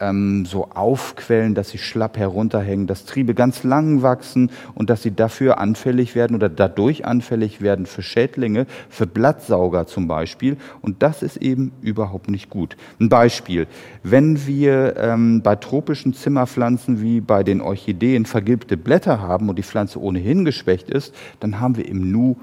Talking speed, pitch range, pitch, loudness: 160 wpm, 100-130 Hz, 115 Hz, -19 LUFS